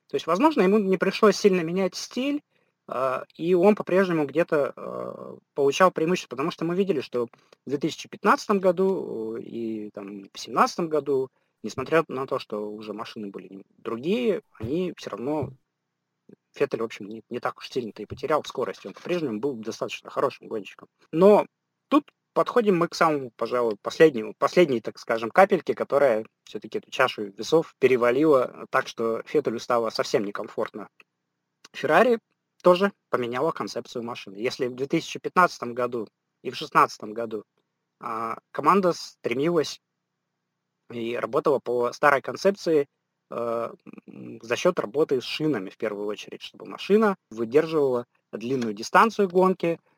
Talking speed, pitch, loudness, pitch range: 140 wpm, 150 Hz, -25 LUFS, 115-185 Hz